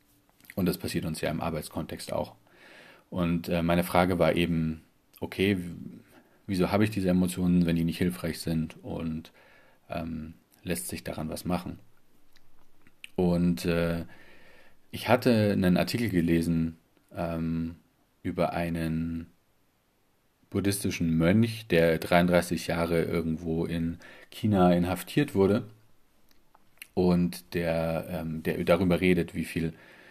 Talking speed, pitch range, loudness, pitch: 120 wpm, 80-90 Hz, -28 LUFS, 85 Hz